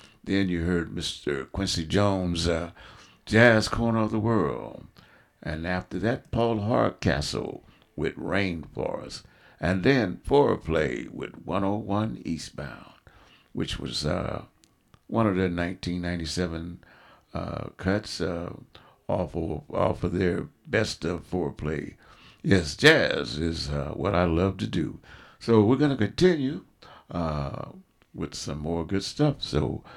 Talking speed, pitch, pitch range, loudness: 130 wpm, 95 Hz, 85-110 Hz, -27 LUFS